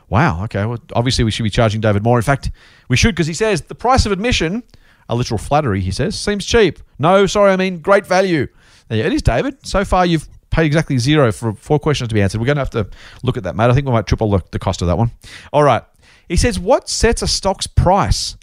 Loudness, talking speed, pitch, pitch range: -16 LUFS, 255 wpm, 125 Hz, 110-175 Hz